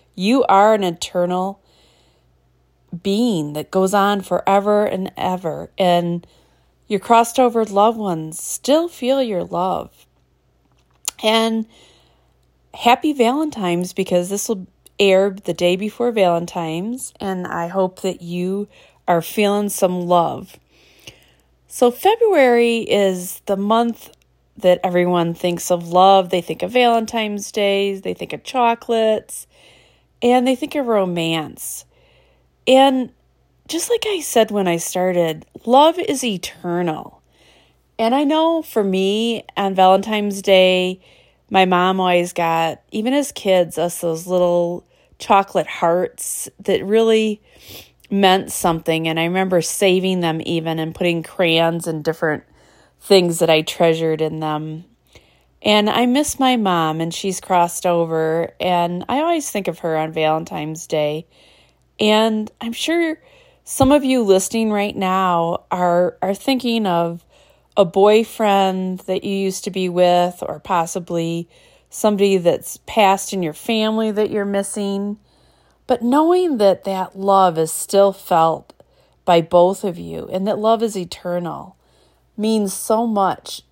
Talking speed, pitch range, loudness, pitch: 135 wpm, 175-220 Hz, -18 LUFS, 190 Hz